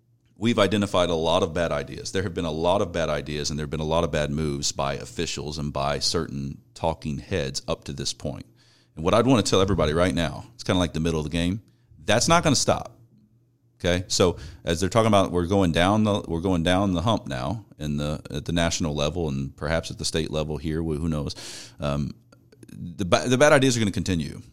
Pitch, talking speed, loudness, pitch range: 85 Hz, 240 wpm, -24 LUFS, 75-105 Hz